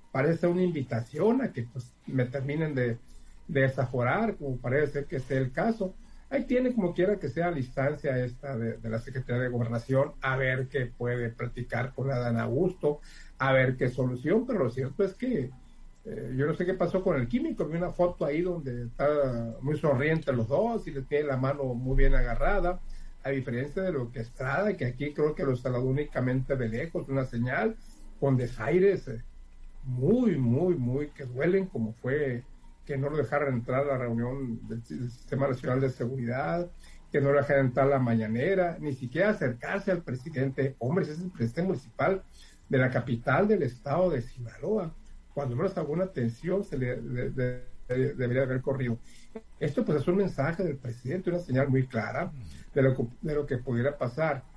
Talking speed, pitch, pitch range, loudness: 195 wpm, 135 Hz, 125-165 Hz, -29 LUFS